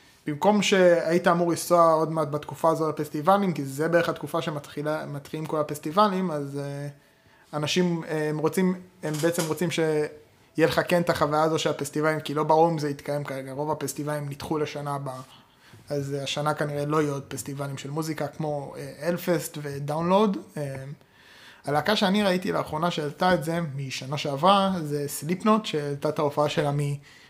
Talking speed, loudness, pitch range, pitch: 160 wpm, -26 LUFS, 145-170 Hz, 155 Hz